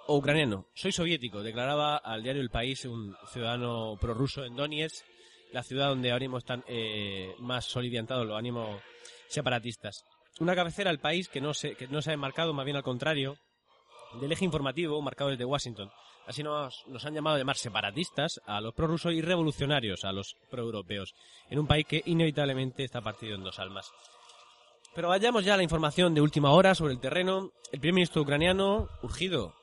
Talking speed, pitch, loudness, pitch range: 180 wpm, 140 Hz, -30 LUFS, 120-155 Hz